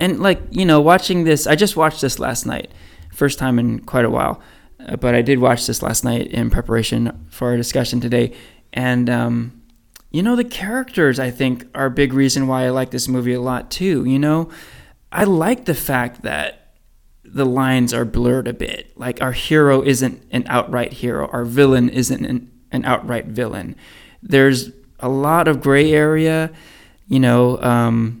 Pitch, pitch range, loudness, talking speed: 130 Hz, 120-150 Hz, -17 LUFS, 185 wpm